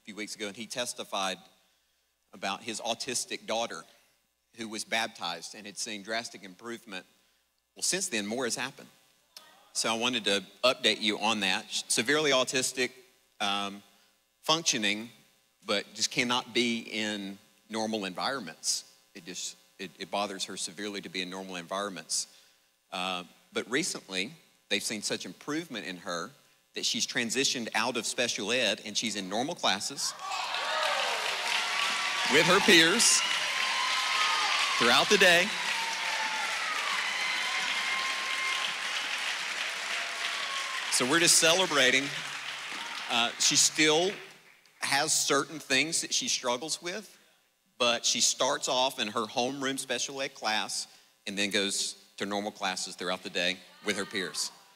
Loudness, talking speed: -28 LUFS, 130 wpm